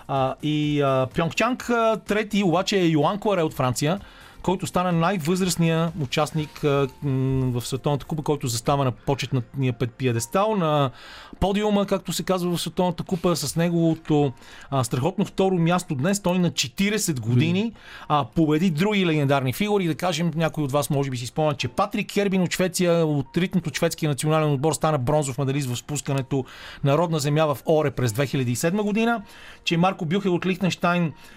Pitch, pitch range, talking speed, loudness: 160 Hz, 140-185 Hz, 170 wpm, -23 LUFS